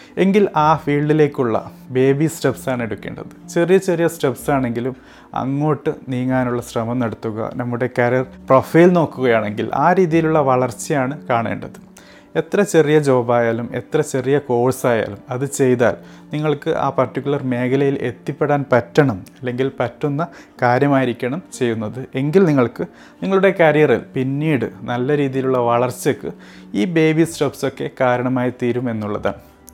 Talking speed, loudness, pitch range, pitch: 105 wpm, -18 LUFS, 125-155 Hz, 135 Hz